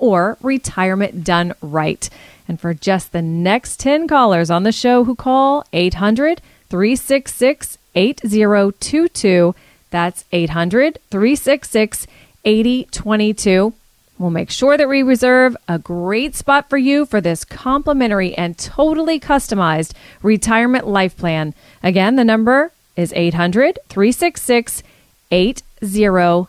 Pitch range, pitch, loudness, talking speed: 180-265 Hz, 215 Hz, -16 LUFS, 115 wpm